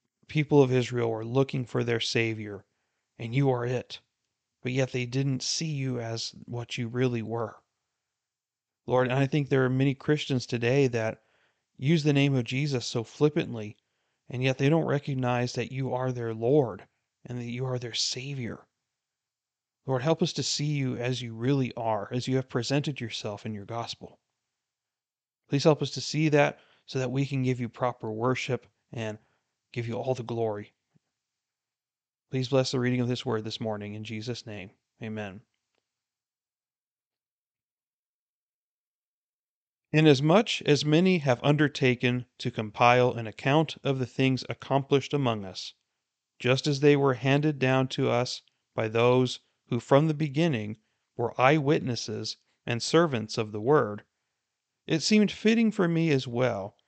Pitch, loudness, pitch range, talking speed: 125 Hz, -27 LUFS, 115-140 Hz, 160 wpm